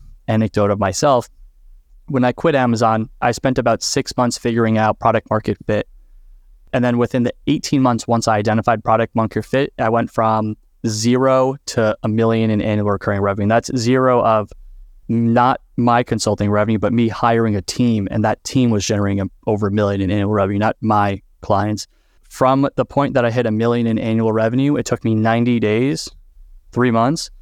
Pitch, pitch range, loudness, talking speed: 115 Hz, 105-120 Hz, -17 LUFS, 185 wpm